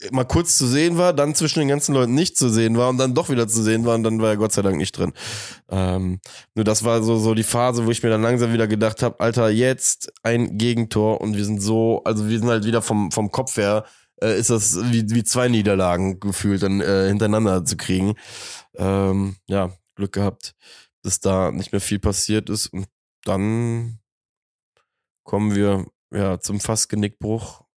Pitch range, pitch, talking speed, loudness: 100-115 Hz, 110 Hz, 205 wpm, -20 LUFS